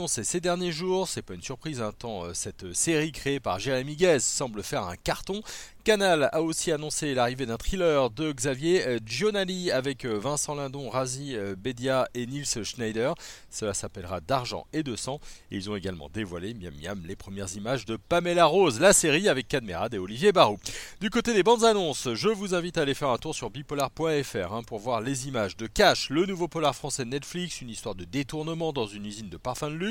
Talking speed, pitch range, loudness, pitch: 205 wpm, 110-160 Hz, -27 LUFS, 135 Hz